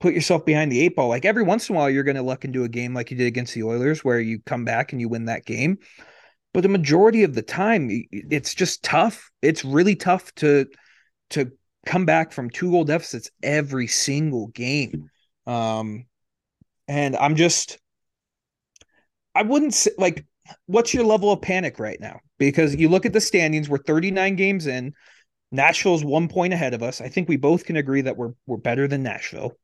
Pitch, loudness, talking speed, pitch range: 145 Hz, -21 LUFS, 200 wpm, 125-180 Hz